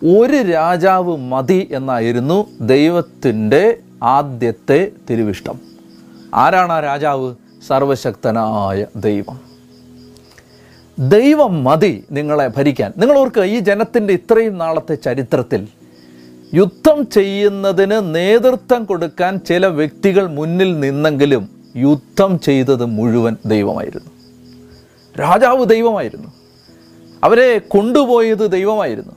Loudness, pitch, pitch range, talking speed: -14 LUFS, 155 Hz, 120-195 Hz, 80 wpm